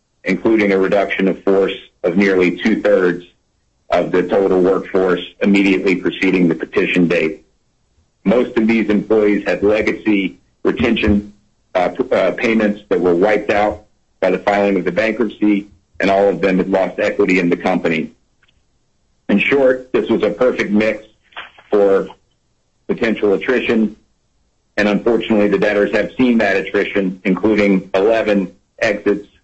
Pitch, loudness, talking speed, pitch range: 100 Hz, -16 LUFS, 145 wpm, 95-105 Hz